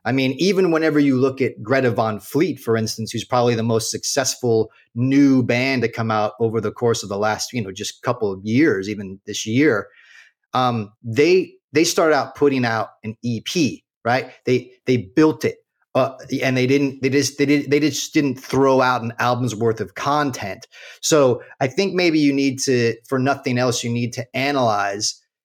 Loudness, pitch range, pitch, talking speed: -20 LUFS, 115-140 Hz, 125 Hz, 195 wpm